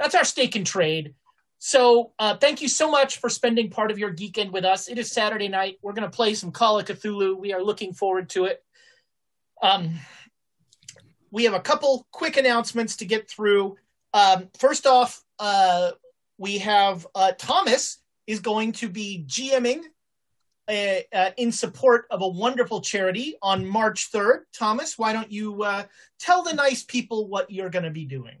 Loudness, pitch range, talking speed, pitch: -23 LUFS, 195-245 Hz, 185 wpm, 215 Hz